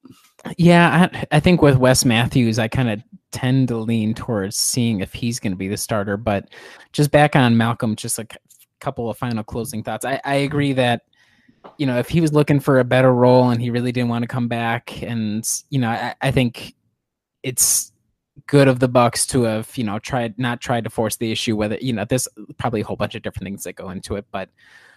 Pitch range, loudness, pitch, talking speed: 110-130 Hz, -19 LUFS, 120 Hz, 230 wpm